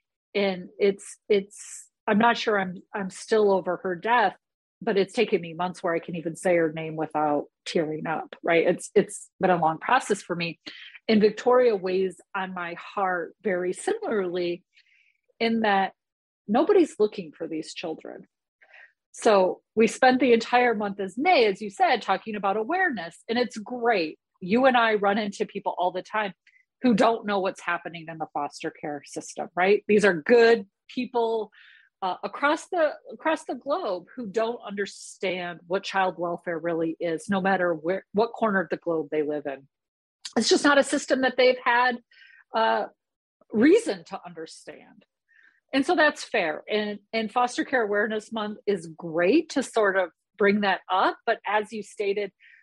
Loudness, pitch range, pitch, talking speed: -25 LUFS, 180-235 Hz, 205 Hz, 170 wpm